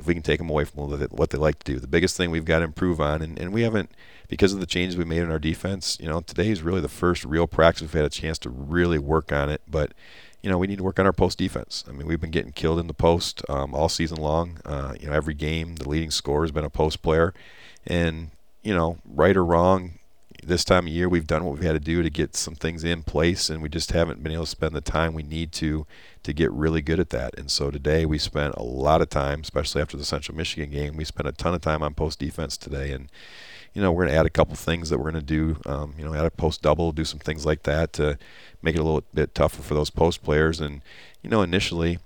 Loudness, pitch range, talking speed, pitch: -25 LUFS, 75-85 Hz, 280 wpm, 80 Hz